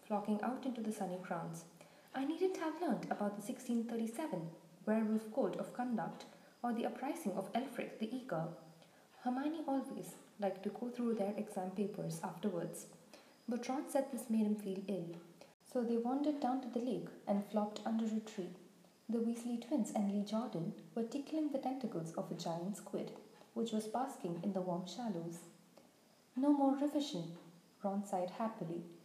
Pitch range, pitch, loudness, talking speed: 185-250 Hz, 215 Hz, -40 LUFS, 165 wpm